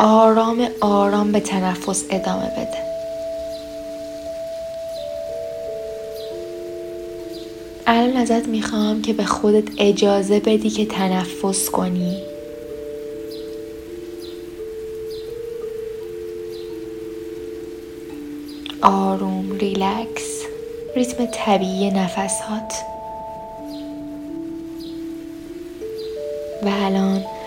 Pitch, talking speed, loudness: 210 Hz, 50 wpm, -22 LUFS